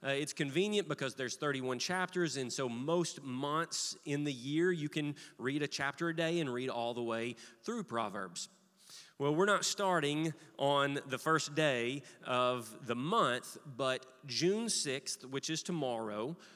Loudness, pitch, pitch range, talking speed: -36 LUFS, 145 Hz, 130-170 Hz, 165 wpm